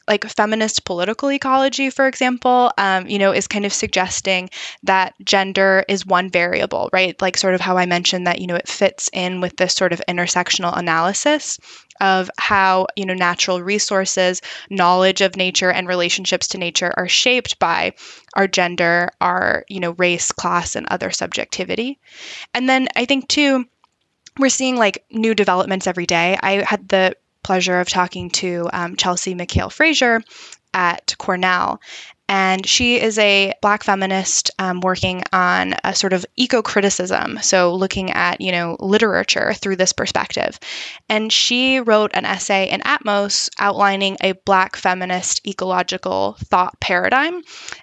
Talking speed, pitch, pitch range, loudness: 155 wpm, 190 Hz, 180-215 Hz, -17 LUFS